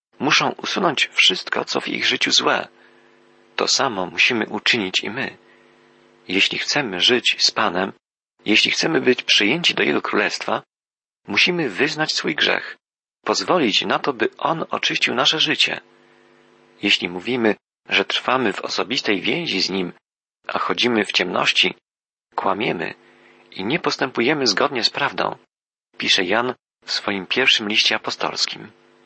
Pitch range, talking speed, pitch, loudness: 90-115 Hz, 135 wpm, 95 Hz, -19 LUFS